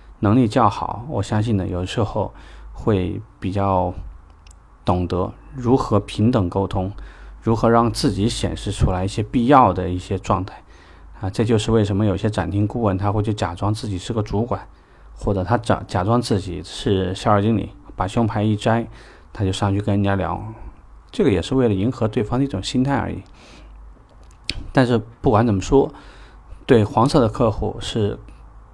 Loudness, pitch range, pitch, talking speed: -20 LUFS, 95-115 Hz, 105 Hz, 255 characters per minute